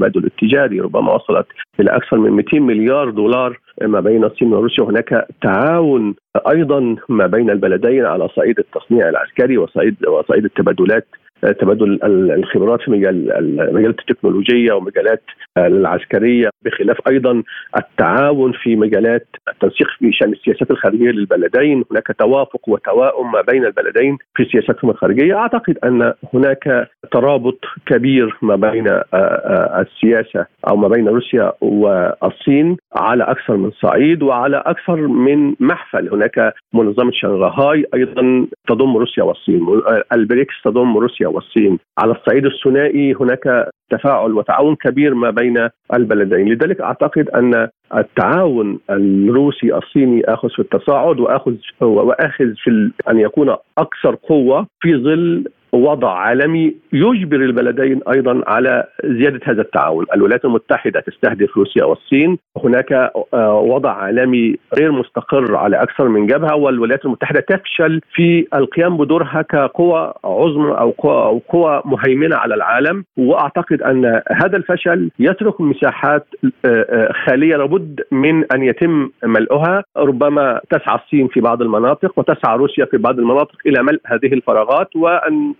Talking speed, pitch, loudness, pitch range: 125 wpm, 135 Hz, -14 LUFS, 120-160 Hz